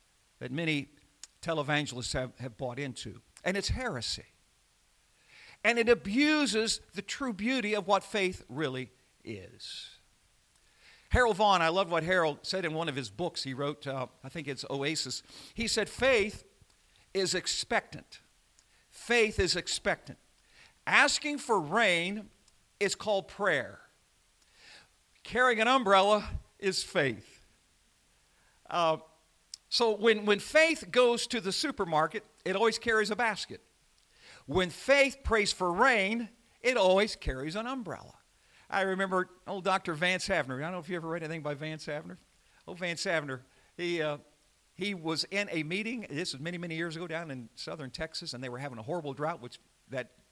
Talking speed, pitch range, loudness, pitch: 155 wpm, 145-210 Hz, -30 LUFS, 175 Hz